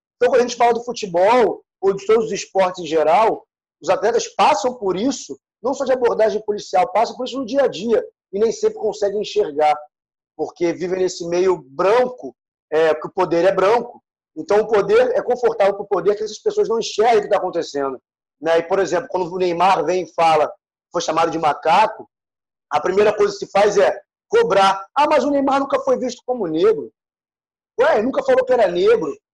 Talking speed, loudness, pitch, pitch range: 205 wpm, -18 LUFS, 210 Hz, 180-280 Hz